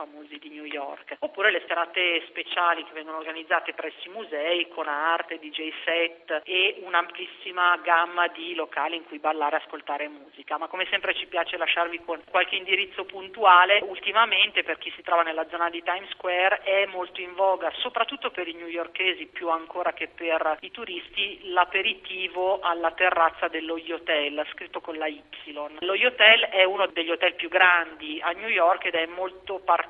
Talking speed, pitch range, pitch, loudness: 175 wpm, 160-185 Hz, 170 Hz, -24 LUFS